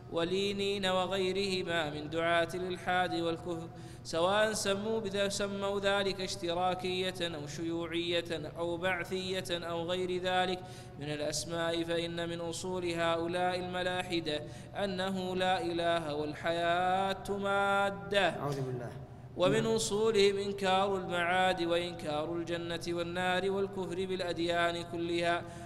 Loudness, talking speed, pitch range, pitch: -33 LUFS, 100 wpm, 170-185 Hz, 175 Hz